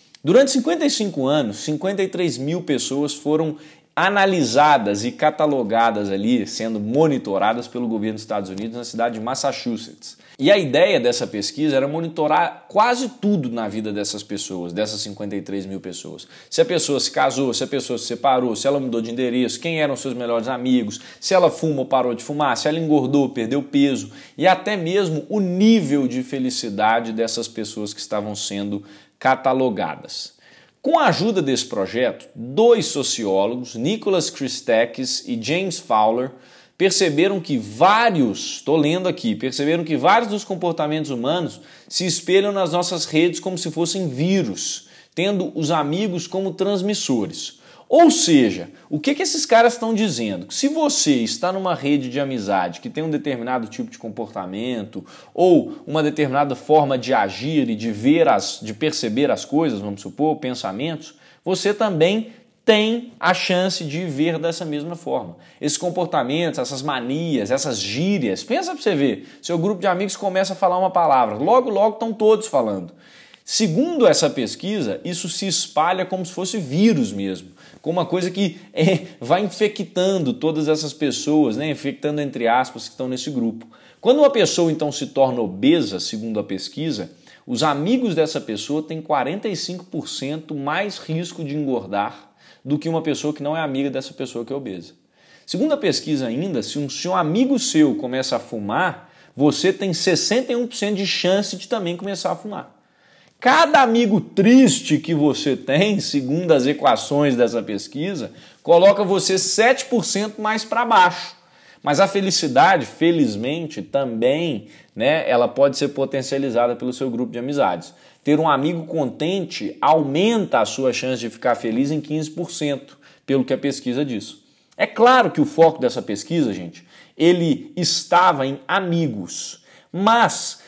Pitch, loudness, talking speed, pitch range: 155 Hz, -20 LUFS, 160 wpm, 130-190 Hz